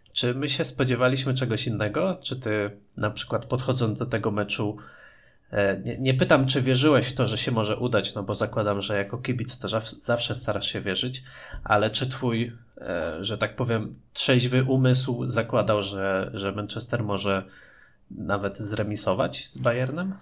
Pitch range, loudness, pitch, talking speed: 105-130 Hz, -26 LUFS, 115 Hz, 155 wpm